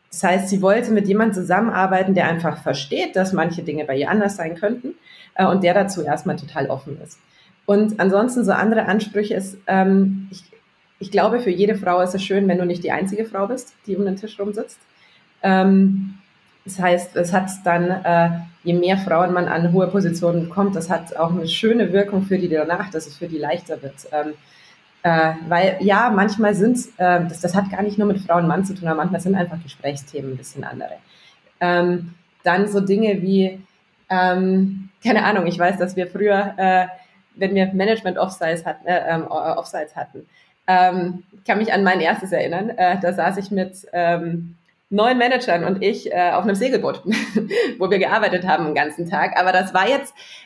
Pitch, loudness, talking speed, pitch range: 185 Hz, -19 LUFS, 195 wpm, 175-200 Hz